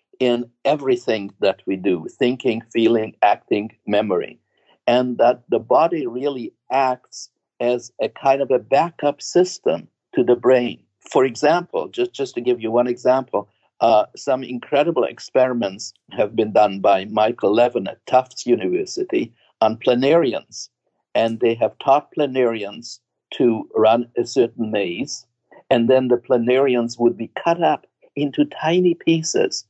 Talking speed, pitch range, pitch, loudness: 140 wpm, 115-145 Hz, 125 Hz, -19 LUFS